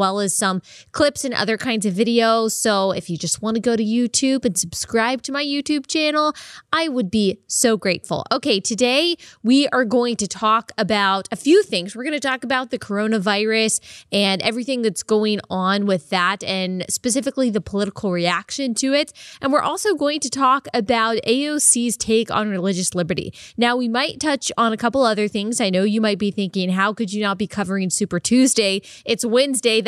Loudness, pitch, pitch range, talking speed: -19 LUFS, 225 Hz, 200-260 Hz, 195 wpm